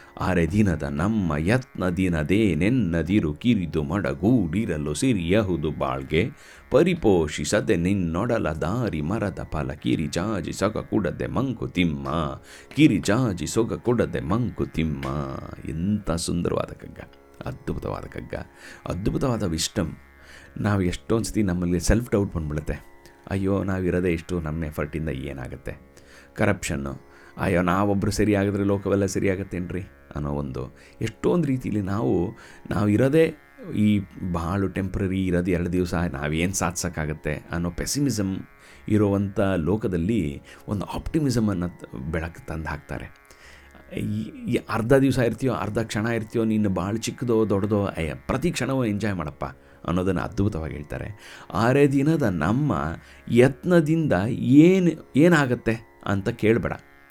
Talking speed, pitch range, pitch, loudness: 105 wpm, 75-105 Hz, 90 Hz, -24 LUFS